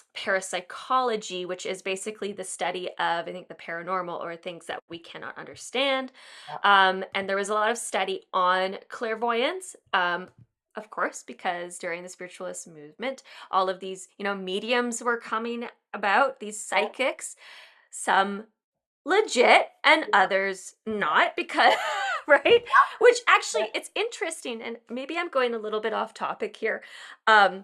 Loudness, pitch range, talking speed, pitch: -25 LUFS, 185-260 Hz, 150 wpm, 210 Hz